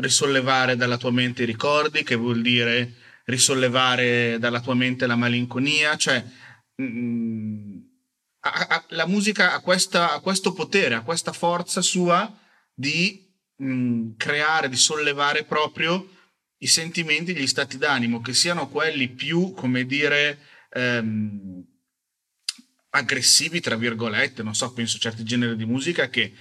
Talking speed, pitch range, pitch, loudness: 135 wpm, 120-165 Hz, 130 Hz, -22 LUFS